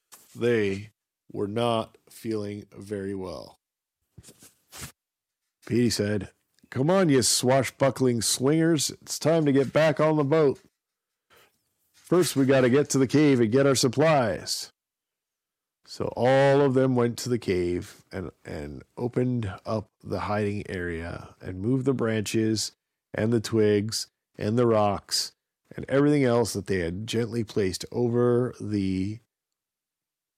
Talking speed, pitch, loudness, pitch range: 135 wpm, 115 Hz, -25 LUFS, 105-135 Hz